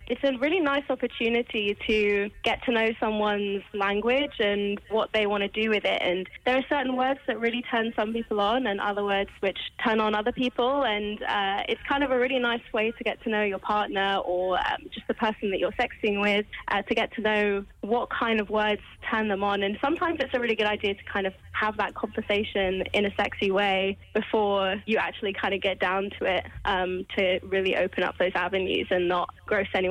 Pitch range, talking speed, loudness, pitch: 200-235 Hz, 225 wpm, -26 LUFS, 210 Hz